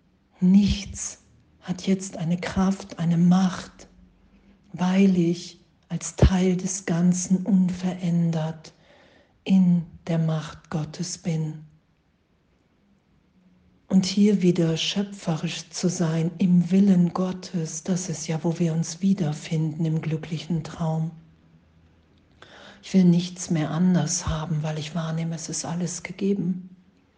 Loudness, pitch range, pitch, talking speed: -24 LUFS, 160-185 Hz, 170 Hz, 115 wpm